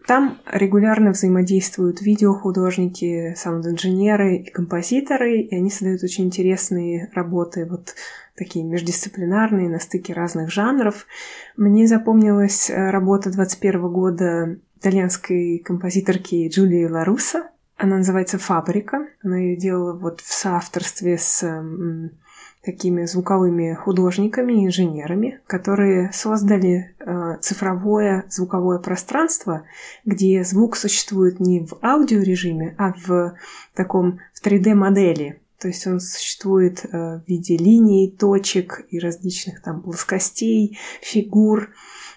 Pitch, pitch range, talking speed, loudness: 185 Hz, 175-205 Hz, 100 wpm, -19 LUFS